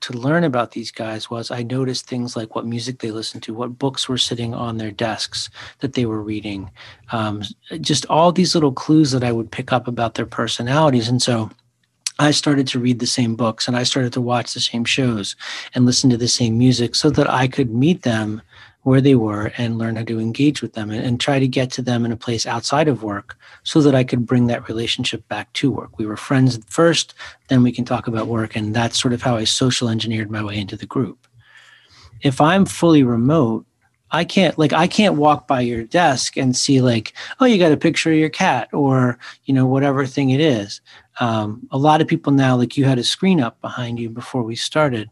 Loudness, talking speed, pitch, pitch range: -18 LUFS, 230 wpm, 125 Hz, 115-140 Hz